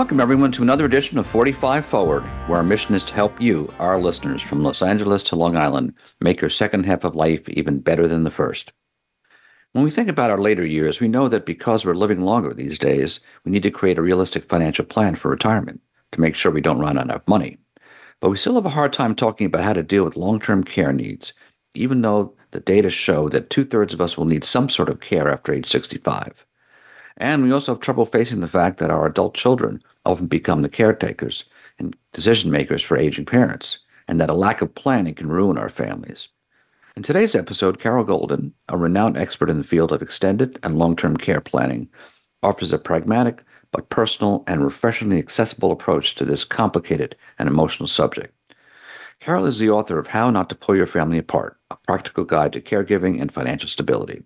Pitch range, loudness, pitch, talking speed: 85-120 Hz, -19 LUFS, 100 Hz, 210 wpm